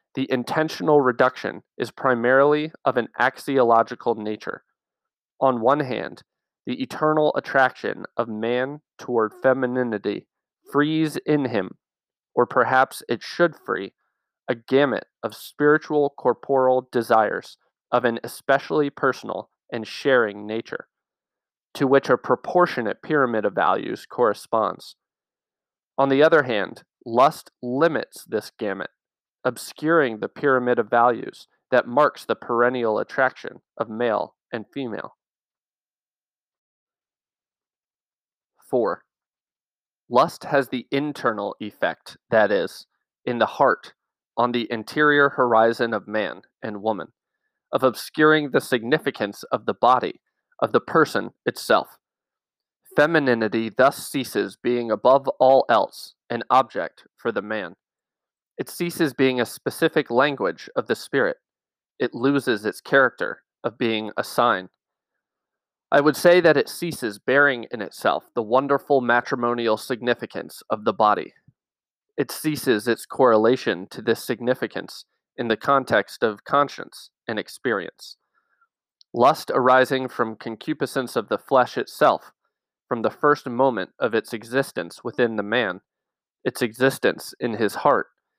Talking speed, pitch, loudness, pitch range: 125 wpm, 130 Hz, -22 LUFS, 120-145 Hz